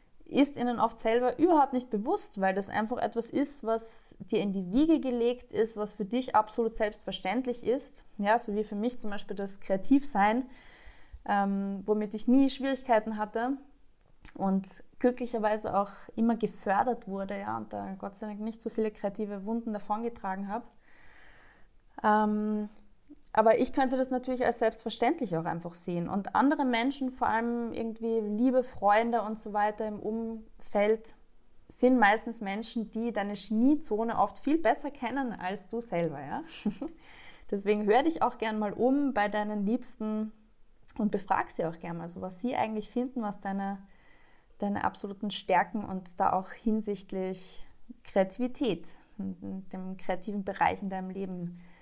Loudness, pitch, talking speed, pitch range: -30 LUFS, 215 Hz, 155 wpm, 200-245 Hz